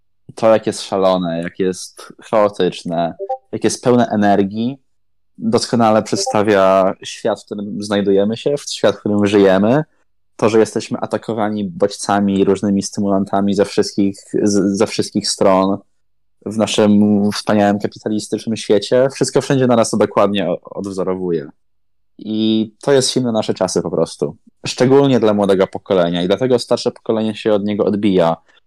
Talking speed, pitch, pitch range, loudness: 140 wpm, 105 Hz, 100-115 Hz, -16 LUFS